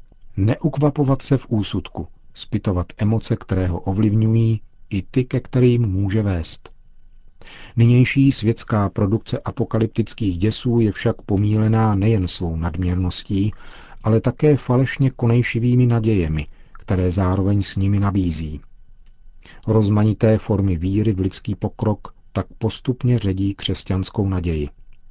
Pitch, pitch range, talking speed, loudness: 105 Hz, 95-115 Hz, 110 wpm, -20 LUFS